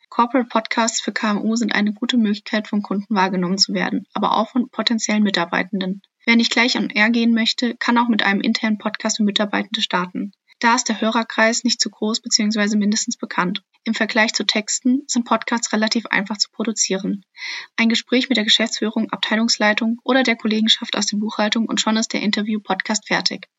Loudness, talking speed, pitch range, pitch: -19 LUFS, 185 wpm, 210-235 Hz, 225 Hz